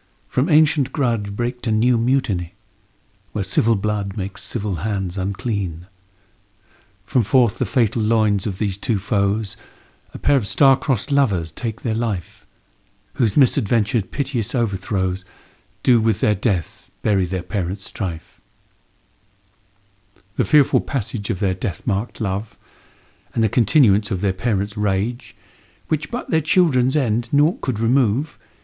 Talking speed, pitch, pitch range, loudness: 140 wpm, 105 Hz, 100-125 Hz, -21 LUFS